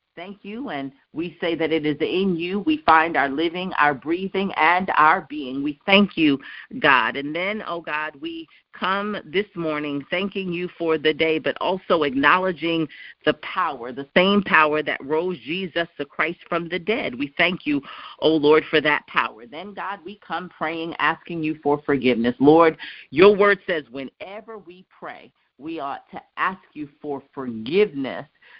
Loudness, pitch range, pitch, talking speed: -21 LUFS, 150-190 Hz, 165 Hz, 175 wpm